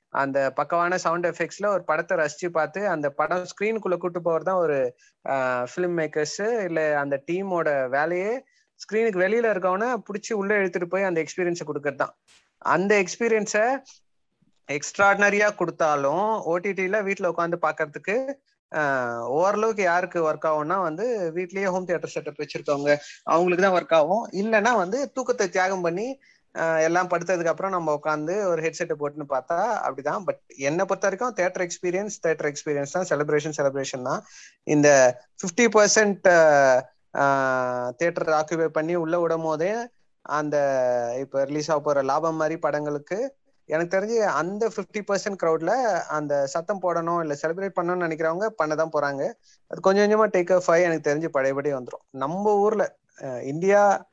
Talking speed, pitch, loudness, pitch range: 140 wpm, 170 Hz, -24 LUFS, 150-195 Hz